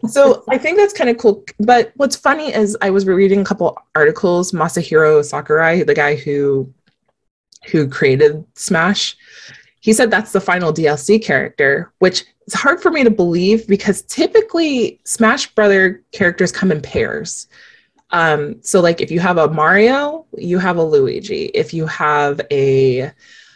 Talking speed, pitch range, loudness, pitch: 160 wpm, 165-245 Hz, -14 LUFS, 200 Hz